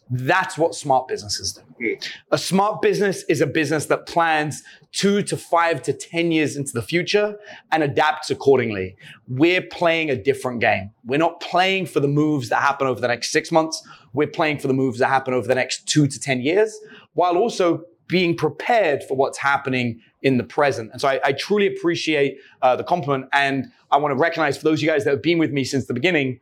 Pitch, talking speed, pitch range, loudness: 155 Hz, 215 wpm, 135-170 Hz, -21 LUFS